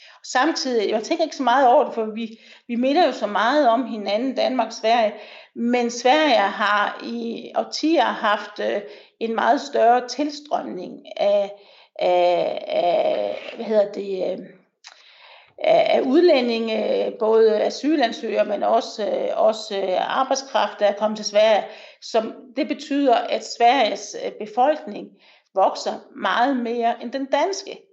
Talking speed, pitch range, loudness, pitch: 130 wpm, 220-305 Hz, -21 LUFS, 240 Hz